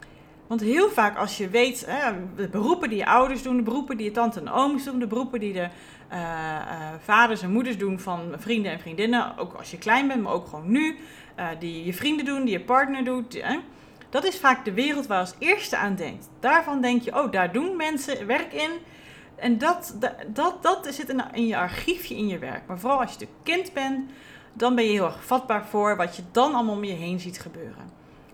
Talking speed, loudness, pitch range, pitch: 220 wpm, -25 LUFS, 200-270 Hz, 235 Hz